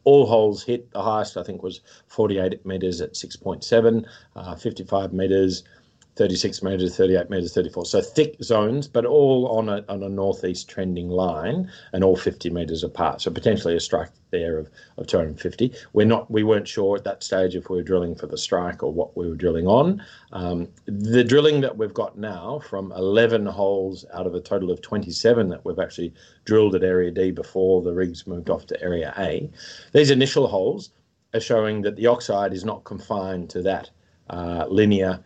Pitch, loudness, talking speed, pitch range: 95 Hz, -22 LUFS, 190 wpm, 90-115 Hz